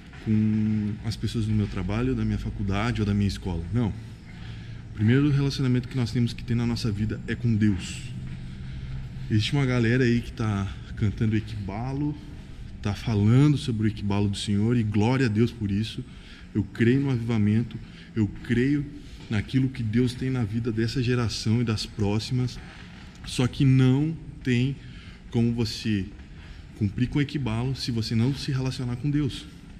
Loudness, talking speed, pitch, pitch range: -26 LUFS, 170 wpm, 115 Hz, 105-125 Hz